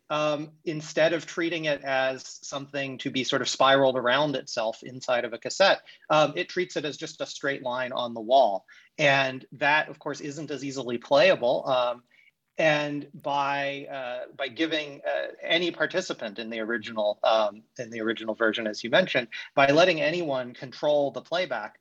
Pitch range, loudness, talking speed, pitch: 125-155 Hz, -26 LUFS, 175 wpm, 140 Hz